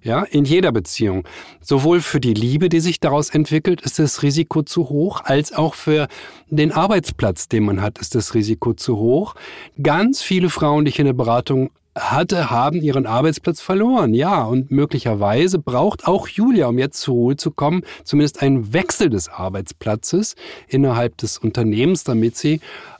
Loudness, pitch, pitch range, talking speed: -18 LUFS, 145 Hz, 120-165 Hz, 170 wpm